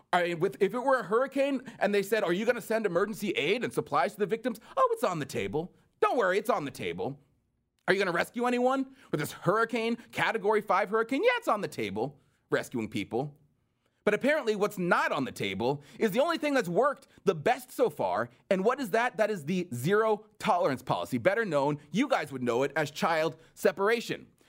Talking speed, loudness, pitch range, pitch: 220 wpm, -29 LUFS, 170-245 Hz, 210 Hz